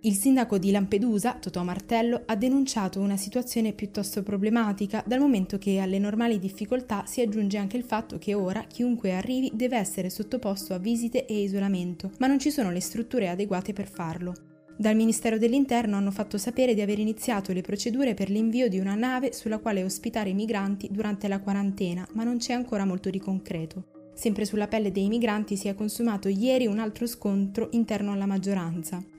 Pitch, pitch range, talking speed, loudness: 210 Hz, 195-235 Hz, 185 wpm, -27 LUFS